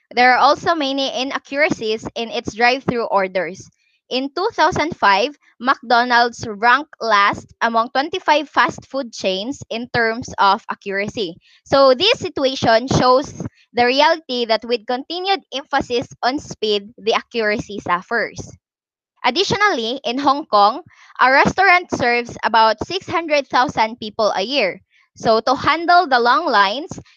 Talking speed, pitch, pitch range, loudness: 125 wpm, 250 Hz, 225-290 Hz, -17 LUFS